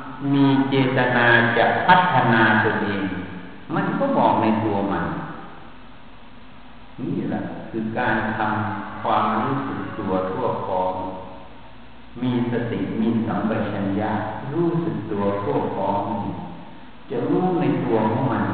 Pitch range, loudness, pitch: 100-125 Hz, -21 LUFS, 110 Hz